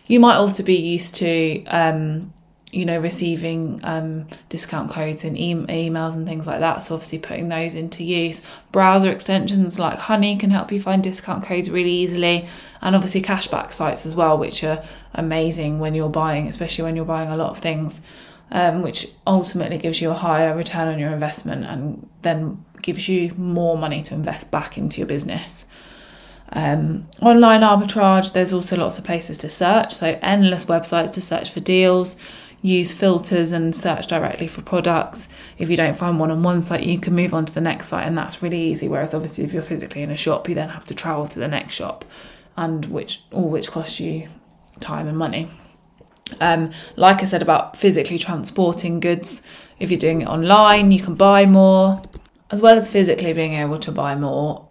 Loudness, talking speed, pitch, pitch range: -19 LUFS, 195 wpm, 170 Hz, 160-185 Hz